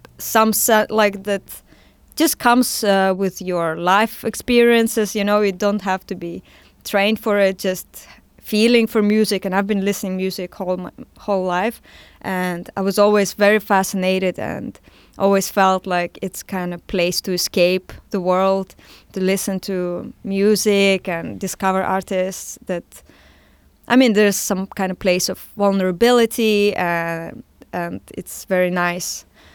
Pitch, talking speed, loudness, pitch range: 195 Hz, 150 wpm, -18 LUFS, 185-210 Hz